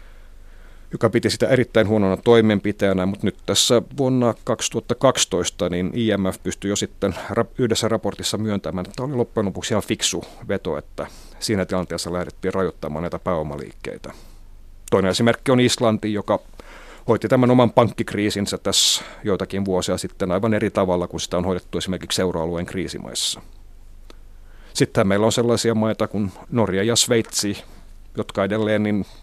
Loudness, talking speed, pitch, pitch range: -21 LUFS, 140 wpm, 100 Hz, 90-110 Hz